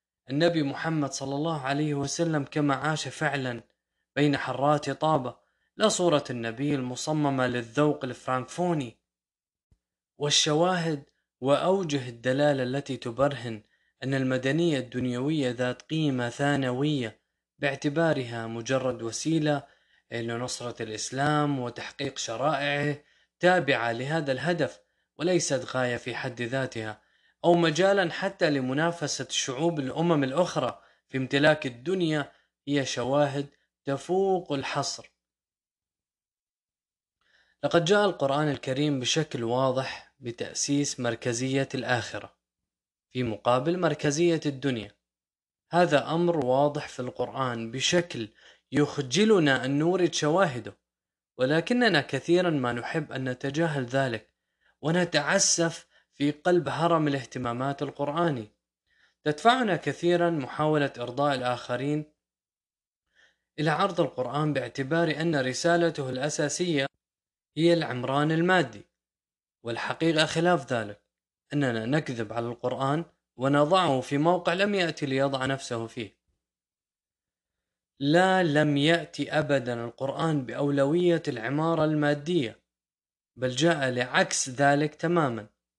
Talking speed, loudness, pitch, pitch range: 95 wpm, -27 LUFS, 140 Hz, 125-160 Hz